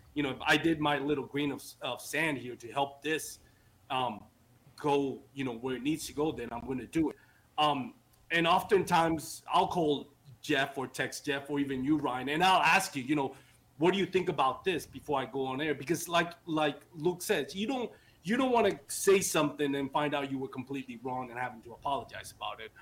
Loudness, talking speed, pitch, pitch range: -32 LUFS, 225 wpm, 145 Hz, 130-160 Hz